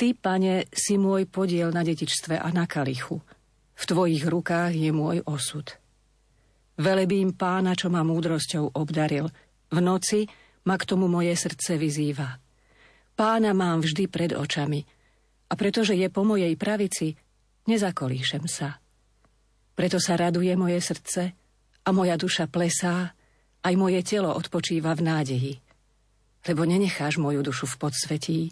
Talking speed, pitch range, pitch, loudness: 135 wpm, 150-185 Hz, 170 Hz, -26 LUFS